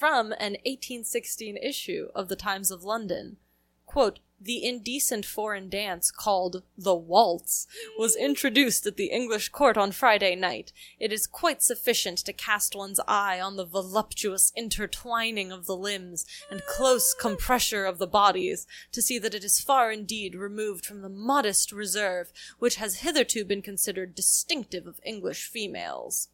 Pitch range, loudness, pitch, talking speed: 195-240 Hz, -26 LUFS, 210 Hz, 155 wpm